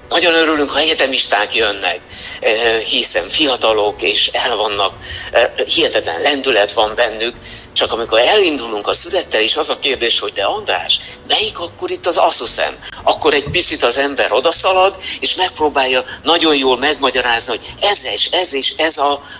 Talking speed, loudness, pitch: 150 wpm, -12 LUFS, 170 Hz